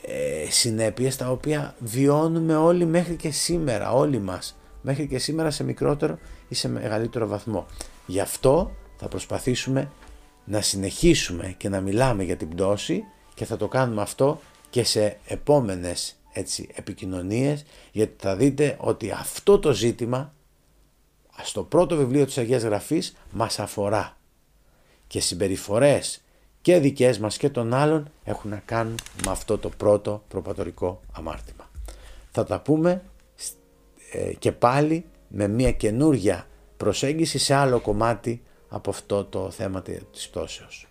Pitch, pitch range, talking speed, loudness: 115 Hz, 100-145 Hz, 135 wpm, -24 LUFS